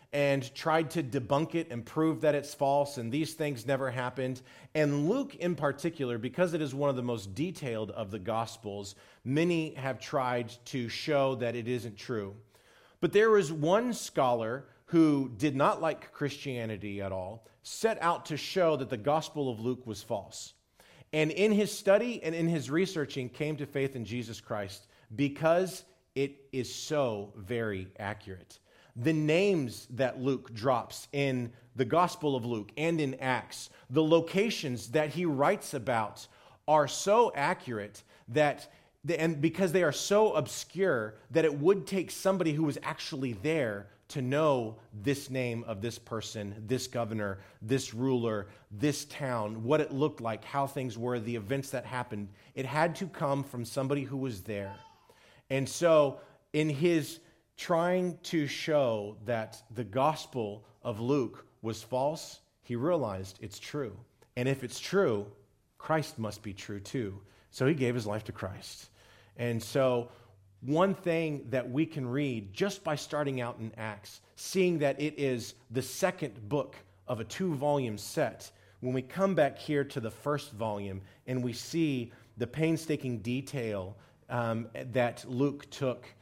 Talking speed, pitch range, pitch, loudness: 160 wpm, 115-155 Hz, 130 Hz, -32 LUFS